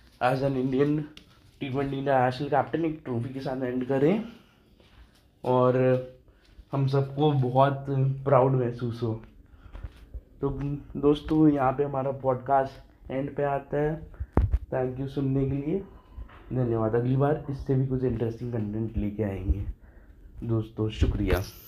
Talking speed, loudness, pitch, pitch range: 135 wpm, -27 LUFS, 130 Hz, 110-140 Hz